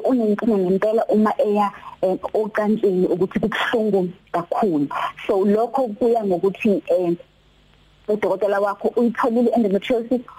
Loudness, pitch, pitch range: -20 LUFS, 210 Hz, 190-235 Hz